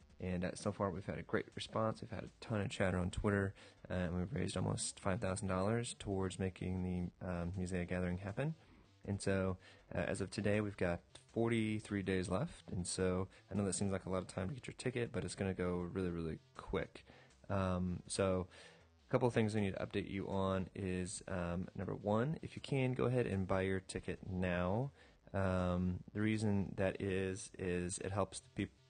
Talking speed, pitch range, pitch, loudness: 205 wpm, 90-105 Hz, 95 Hz, -40 LUFS